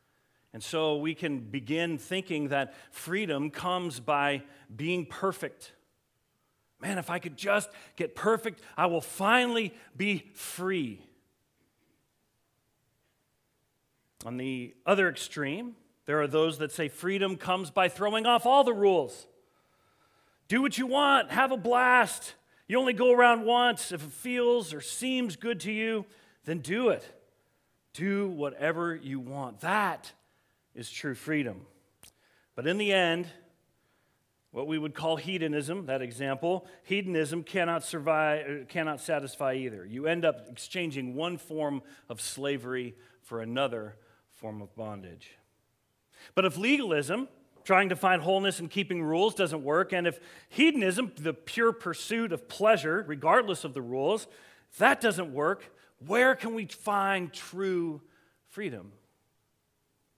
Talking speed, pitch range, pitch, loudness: 135 wpm, 140-205 Hz, 170 Hz, -29 LUFS